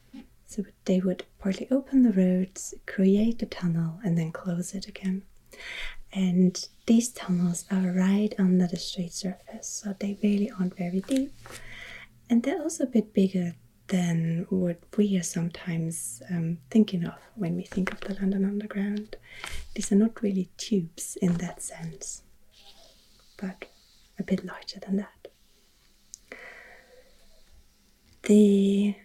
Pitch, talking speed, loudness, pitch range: 190 Hz, 135 wpm, -27 LUFS, 180-210 Hz